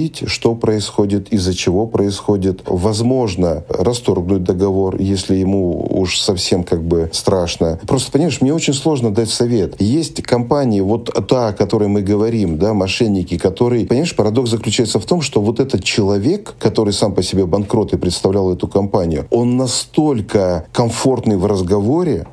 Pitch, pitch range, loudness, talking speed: 105 Hz, 95-120 Hz, -16 LUFS, 150 wpm